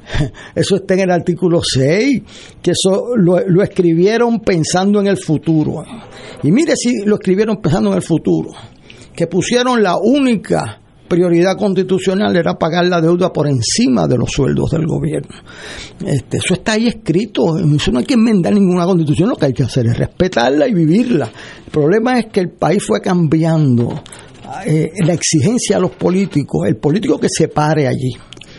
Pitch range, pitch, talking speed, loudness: 155-205 Hz, 180 Hz, 170 wpm, -14 LUFS